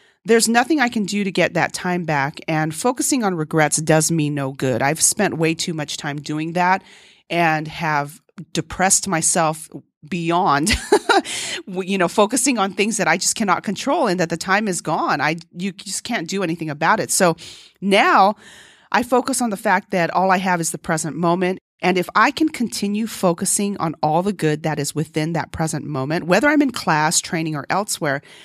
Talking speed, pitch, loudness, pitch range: 195 wpm, 175 Hz, -19 LUFS, 160-200 Hz